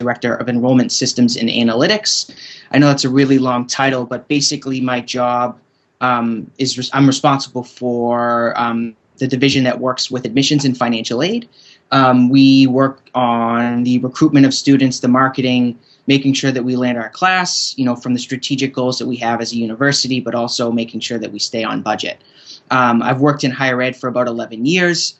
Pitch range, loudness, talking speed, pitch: 120-135 Hz, -15 LUFS, 195 wpm, 125 Hz